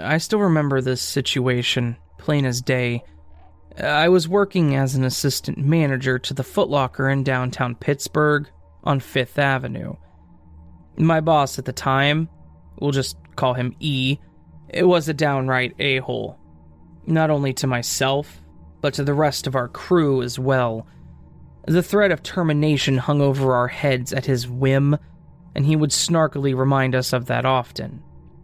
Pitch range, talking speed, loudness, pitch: 125-145 Hz, 155 wpm, -20 LUFS, 135 Hz